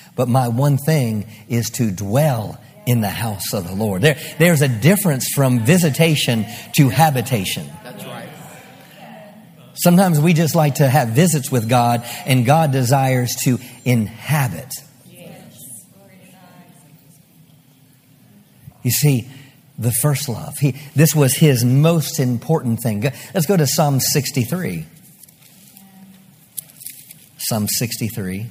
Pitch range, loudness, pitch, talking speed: 125-160 Hz, -17 LUFS, 140 Hz, 120 wpm